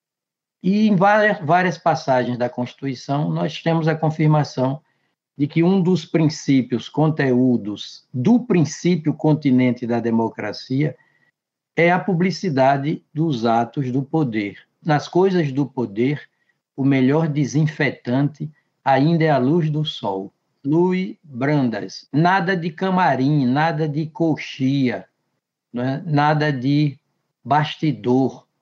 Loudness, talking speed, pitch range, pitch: -20 LUFS, 115 wpm, 130-165 Hz, 150 Hz